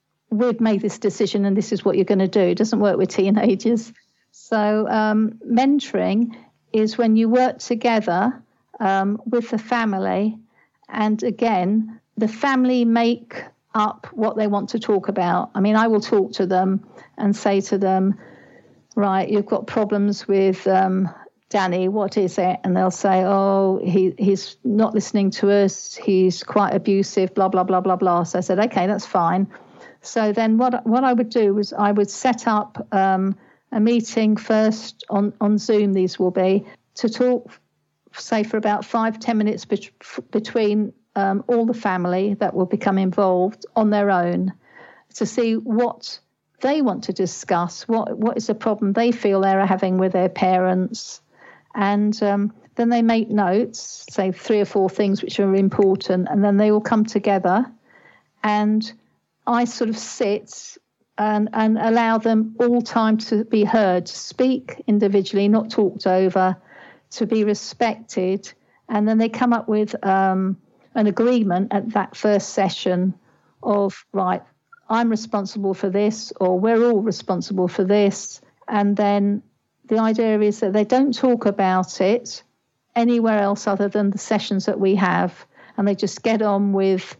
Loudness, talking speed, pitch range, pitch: -20 LUFS, 170 wpm, 195-225 Hz, 210 Hz